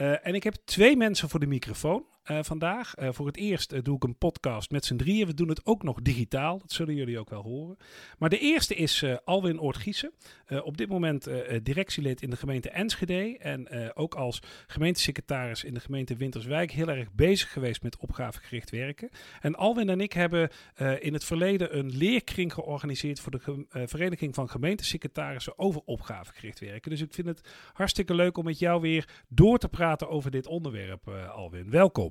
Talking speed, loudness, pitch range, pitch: 205 wpm, -29 LUFS, 130-175 Hz, 150 Hz